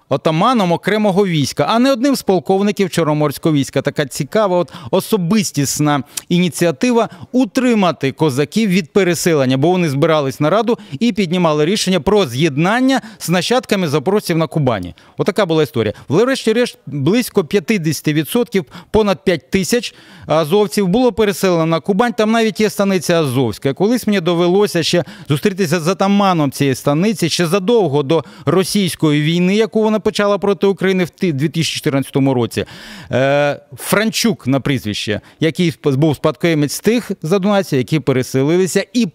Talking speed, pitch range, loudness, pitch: 135 wpm, 150-205 Hz, -15 LUFS, 175 Hz